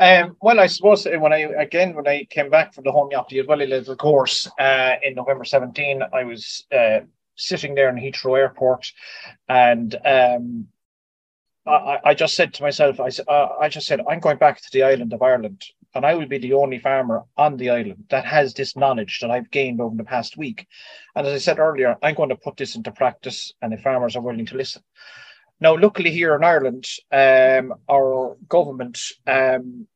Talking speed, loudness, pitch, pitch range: 200 wpm, -19 LUFS, 135 Hz, 125-150 Hz